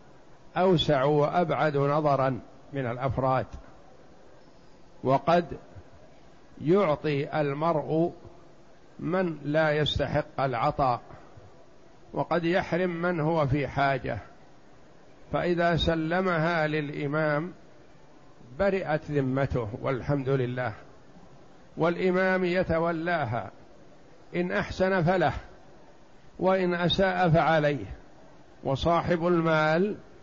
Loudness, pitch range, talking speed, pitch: -27 LUFS, 140-175 Hz, 70 wpm, 155 Hz